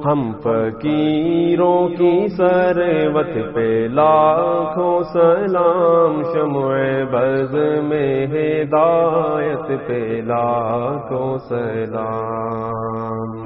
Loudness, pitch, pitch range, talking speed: -17 LUFS, 150 Hz, 120-165 Hz, 65 wpm